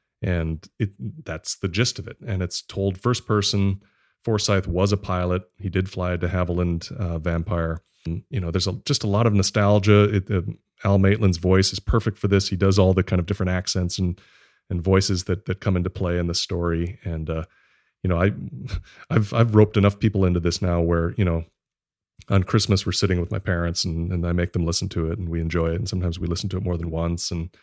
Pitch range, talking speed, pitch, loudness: 85-100 Hz, 230 wpm, 95 Hz, -23 LUFS